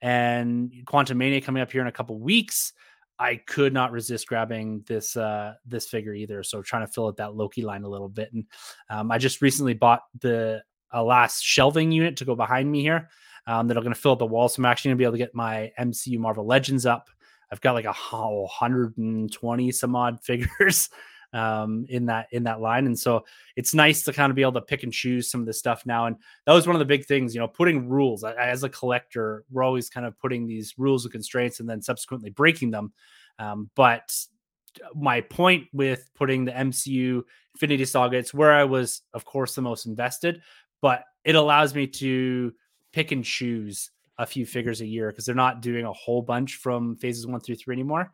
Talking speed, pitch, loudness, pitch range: 225 wpm, 125 Hz, -24 LUFS, 115-135 Hz